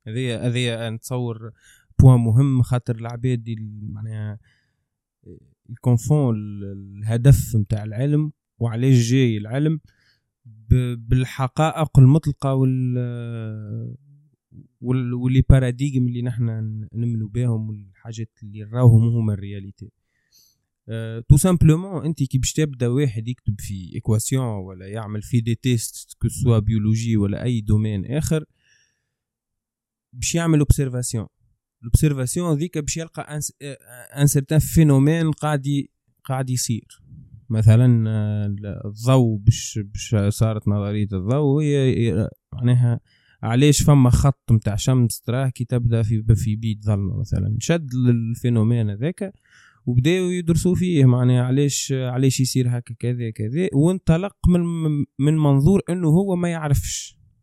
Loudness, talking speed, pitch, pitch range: -20 LUFS, 115 wpm, 125 Hz, 110-140 Hz